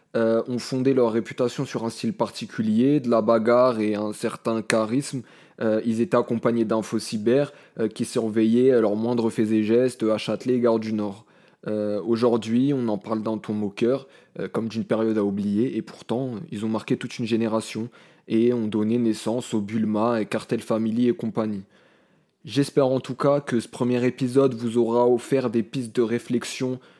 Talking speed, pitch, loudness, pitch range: 190 wpm, 115 Hz, -24 LUFS, 110-125 Hz